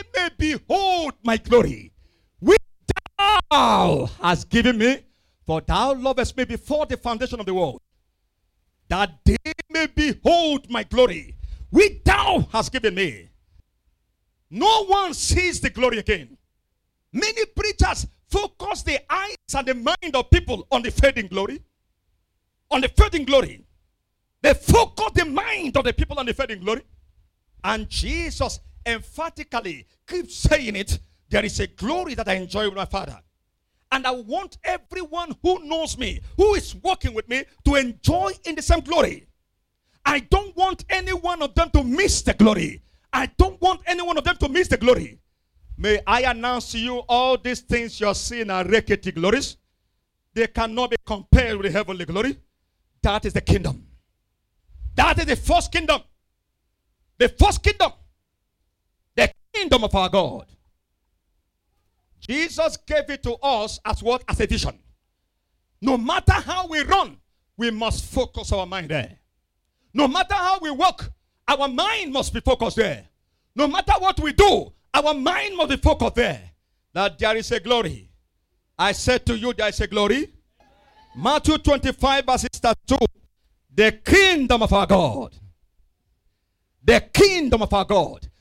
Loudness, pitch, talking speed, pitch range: -21 LUFS, 245 Hz, 155 wpm, 185-315 Hz